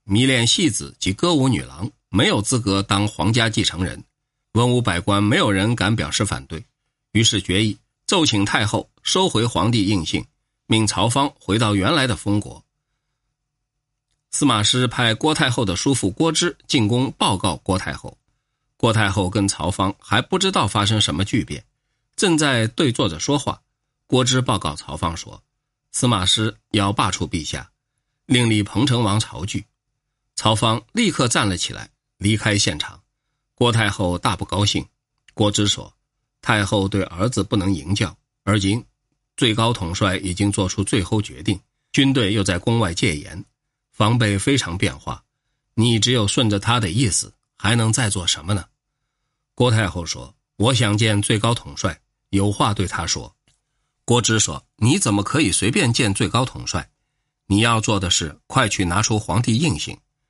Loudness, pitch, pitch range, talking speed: -19 LUFS, 110 Hz, 100-130 Hz, 235 characters per minute